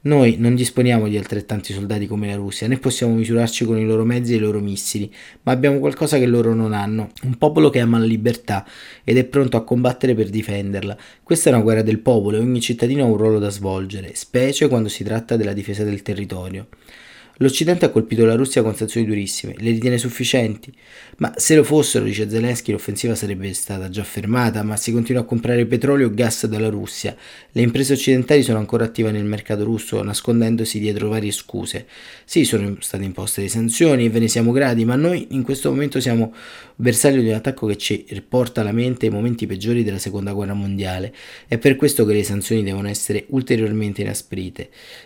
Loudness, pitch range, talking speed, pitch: -19 LUFS, 105-125 Hz, 200 wpm, 115 Hz